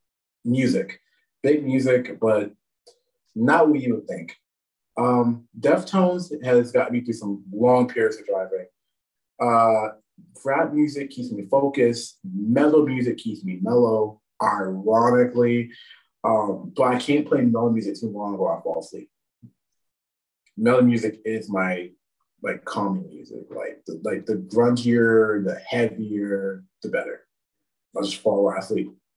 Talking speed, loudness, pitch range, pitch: 135 wpm, -22 LUFS, 110-145 Hz, 120 Hz